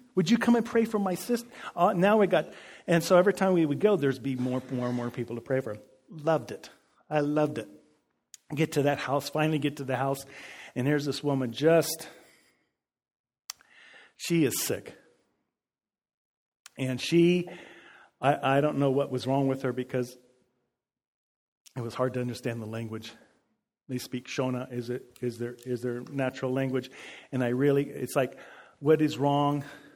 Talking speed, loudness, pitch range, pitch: 180 wpm, -28 LUFS, 125-155 Hz, 135 Hz